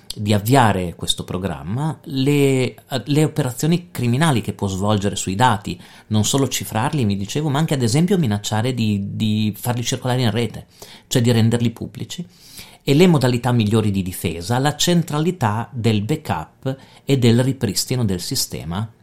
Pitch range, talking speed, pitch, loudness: 105-140 Hz, 150 wpm, 120 Hz, -19 LUFS